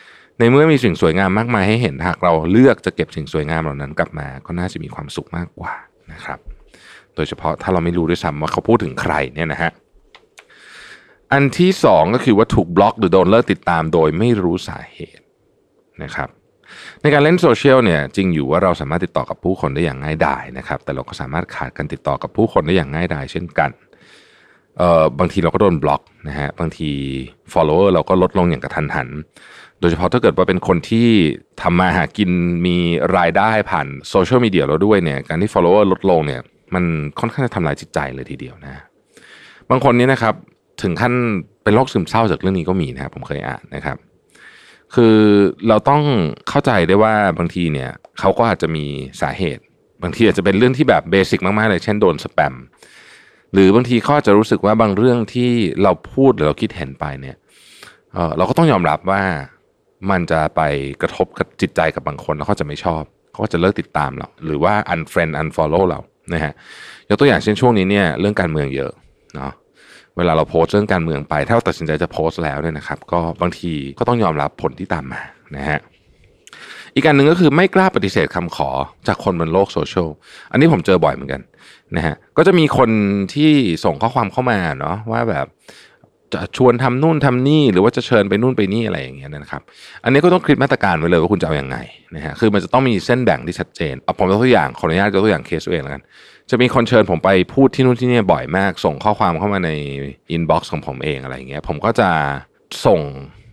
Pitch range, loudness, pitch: 80-115 Hz, -16 LUFS, 95 Hz